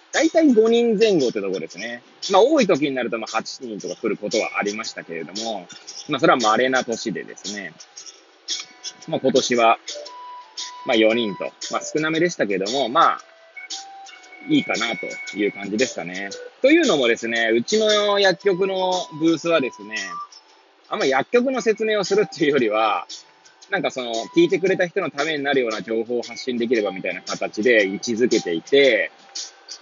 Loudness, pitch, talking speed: -20 LUFS, 165 Hz, 345 characters per minute